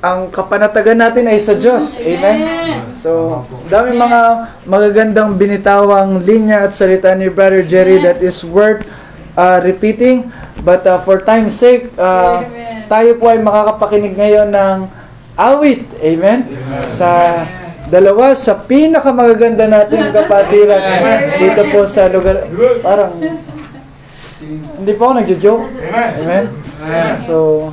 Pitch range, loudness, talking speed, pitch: 180-225 Hz, -10 LUFS, 120 wpm, 200 Hz